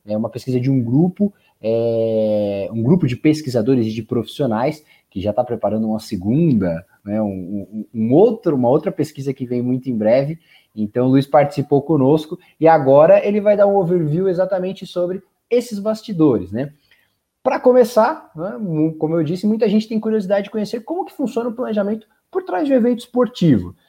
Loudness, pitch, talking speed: -18 LUFS, 155 Hz, 185 wpm